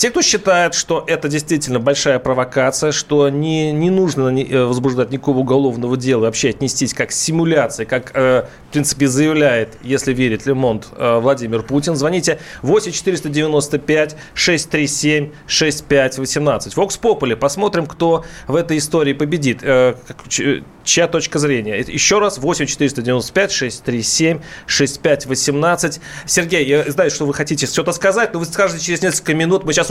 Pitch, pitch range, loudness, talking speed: 150 Hz, 130-165 Hz, -16 LUFS, 125 wpm